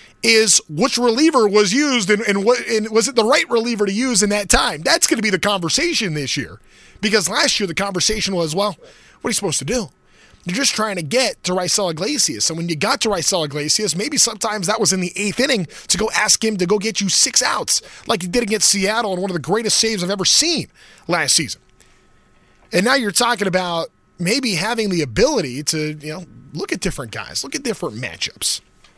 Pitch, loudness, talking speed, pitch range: 210 Hz, -17 LUFS, 225 wpm, 180-230 Hz